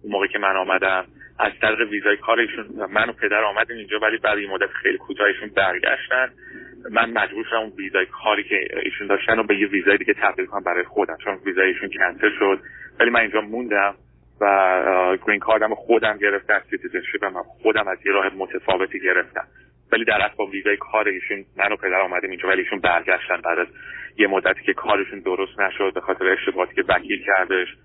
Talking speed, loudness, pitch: 195 wpm, -20 LUFS, 110 Hz